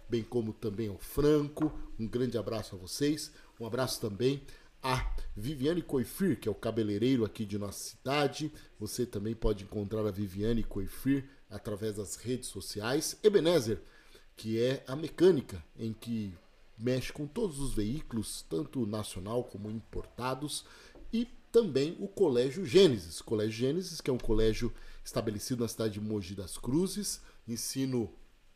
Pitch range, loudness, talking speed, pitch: 105-140 Hz, -33 LUFS, 150 wpm, 120 Hz